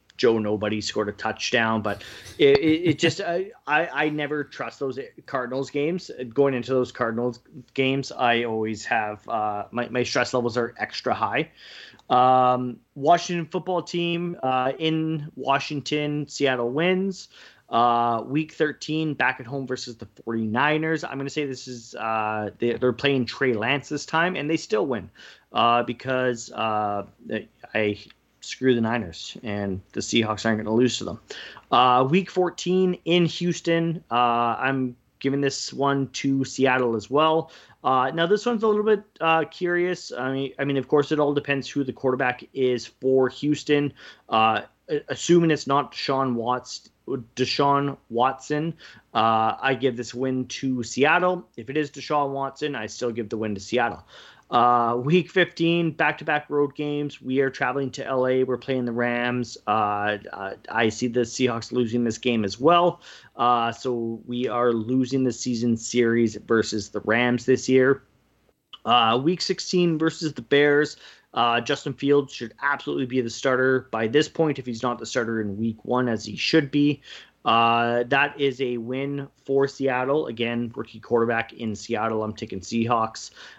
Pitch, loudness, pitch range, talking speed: 130 Hz, -24 LUFS, 120-145 Hz, 165 wpm